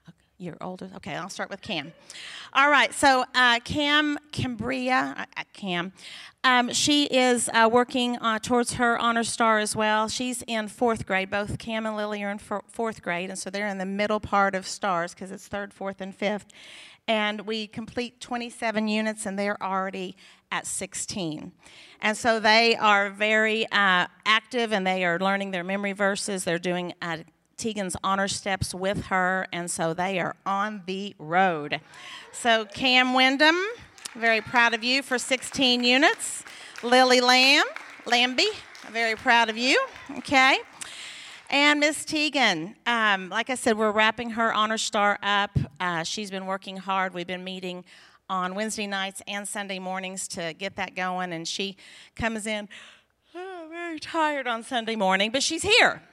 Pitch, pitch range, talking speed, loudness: 215 Hz, 190-245 Hz, 165 wpm, -24 LUFS